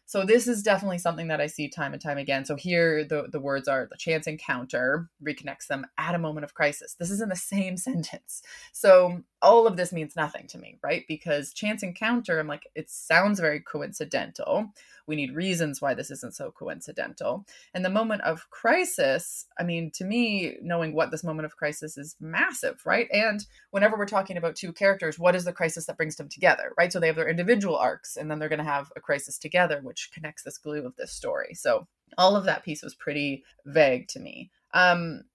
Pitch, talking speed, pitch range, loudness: 170 Hz, 215 wpm, 155-195 Hz, -26 LUFS